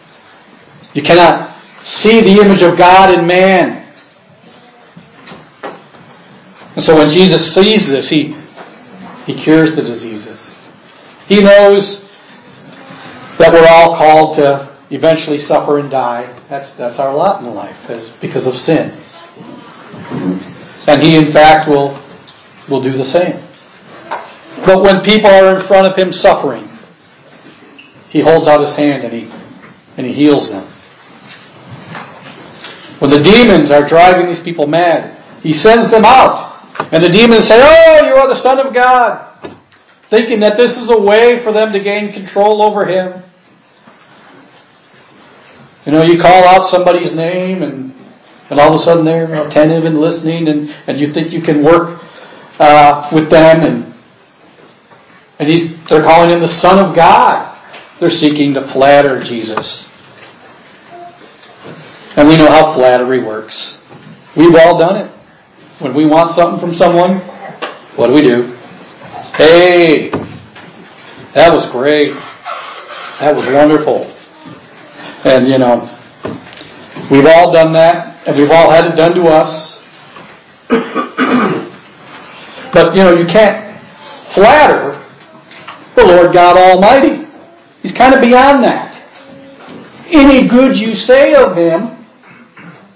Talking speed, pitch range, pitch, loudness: 135 wpm, 150-200 Hz, 165 Hz, -8 LUFS